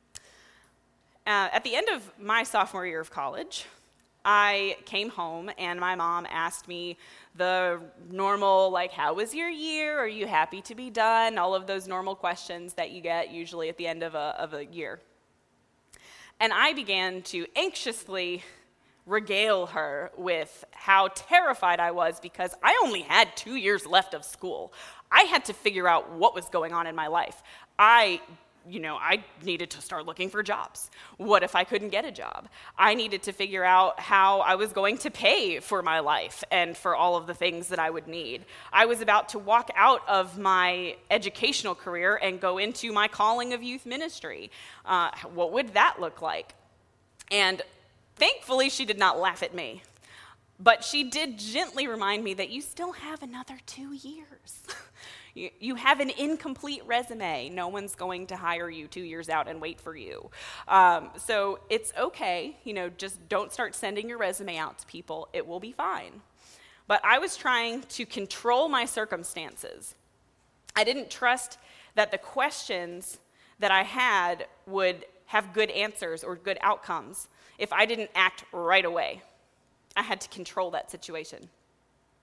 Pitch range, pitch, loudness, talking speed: 180-240 Hz, 195 Hz, -26 LUFS, 175 wpm